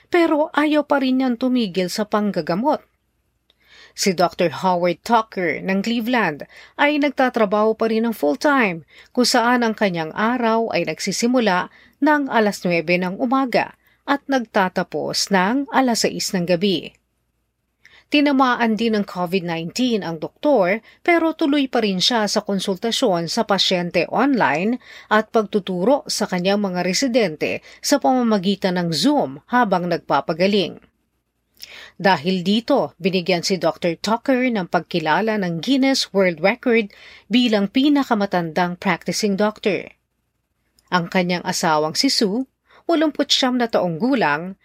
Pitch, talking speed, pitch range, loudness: 215 Hz, 125 wpm, 185-250 Hz, -19 LUFS